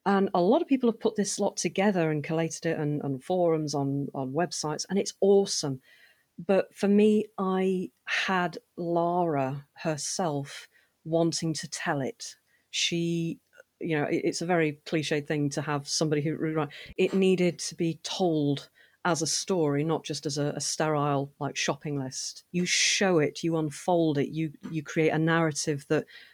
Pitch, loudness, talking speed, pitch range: 165 Hz, -28 LUFS, 170 wpm, 150-185 Hz